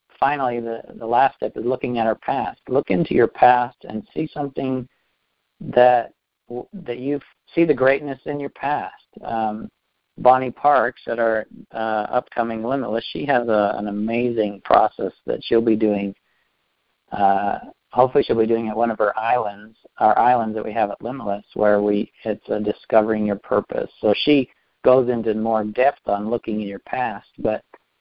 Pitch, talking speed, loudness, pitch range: 115 Hz, 170 wpm, -21 LUFS, 110-125 Hz